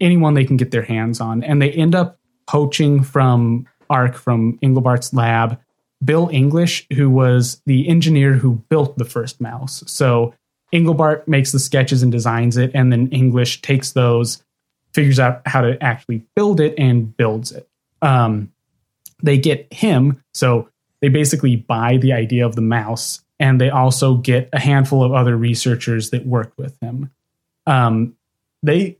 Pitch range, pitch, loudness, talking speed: 120-145 Hz, 130 Hz, -16 LUFS, 165 wpm